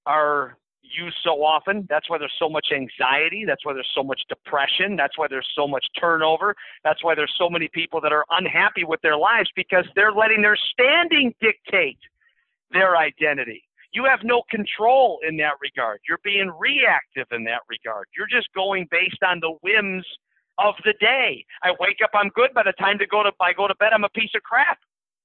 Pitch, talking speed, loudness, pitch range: 195 Hz, 200 wpm, -20 LUFS, 165-215 Hz